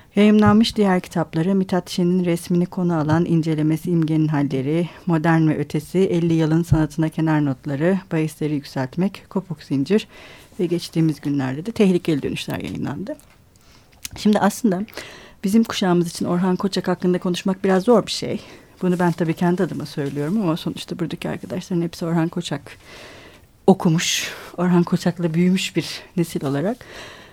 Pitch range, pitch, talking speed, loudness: 160-185 Hz, 175 Hz, 140 wpm, -21 LUFS